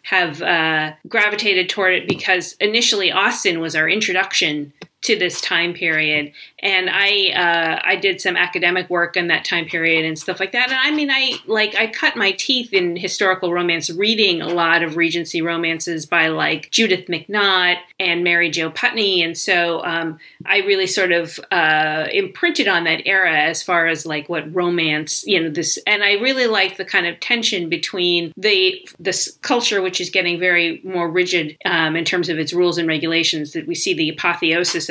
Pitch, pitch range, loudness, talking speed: 175 Hz, 165-200 Hz, -17 LUFS, 185 wpm